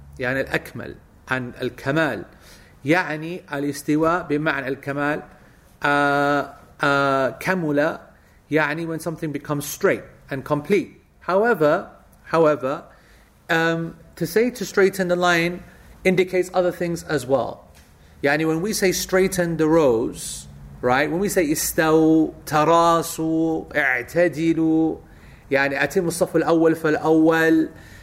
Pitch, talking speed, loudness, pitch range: 160 Hz, 110 wpm, -21 LUFS, 140-170 Hz